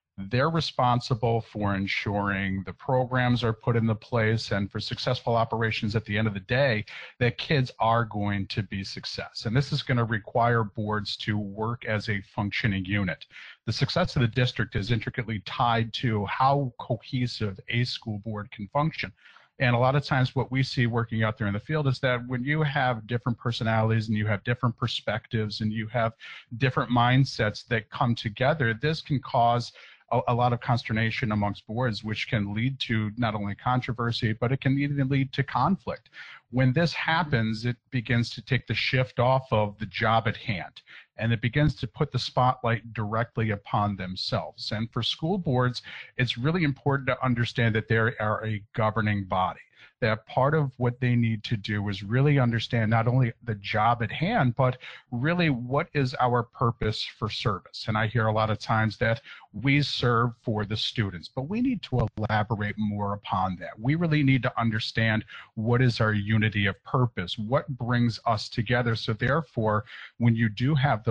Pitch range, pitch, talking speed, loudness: 110-130 Hz, 120 Hz, 185 wpm, -27 LUFS